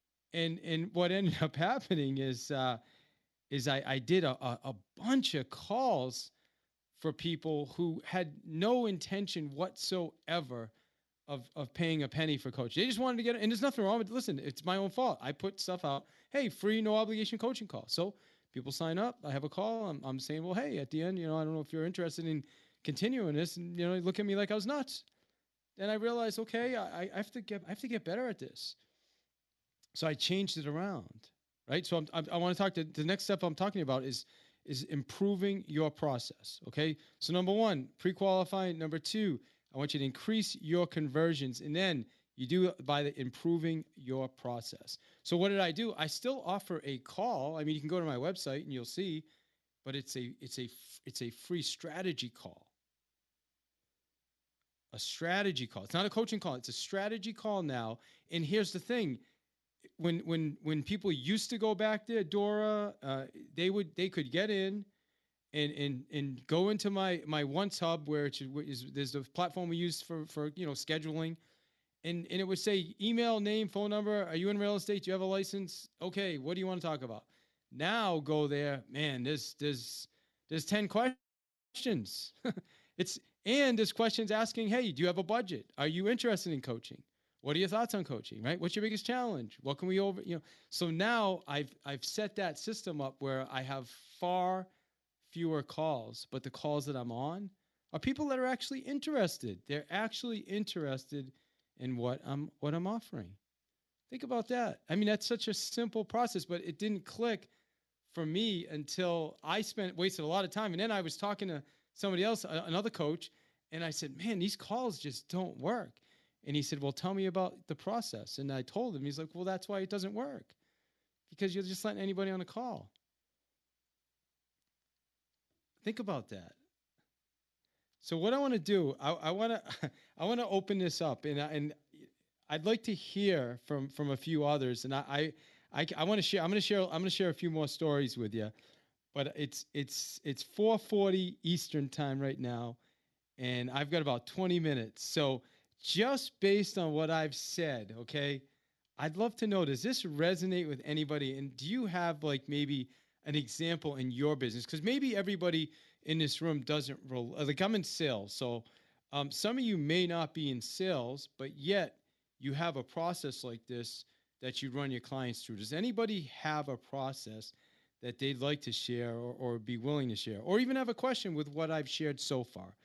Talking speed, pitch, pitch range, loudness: 200 wpm, 165 Hz, 140-195 Hz, -36 LUFS